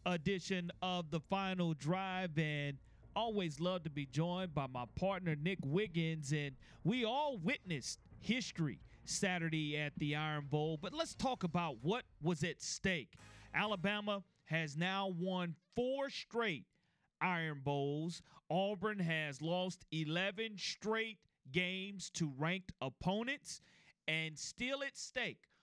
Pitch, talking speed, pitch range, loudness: 175 Hz, 130 wpm, 155-195 Hz, -40 LUFS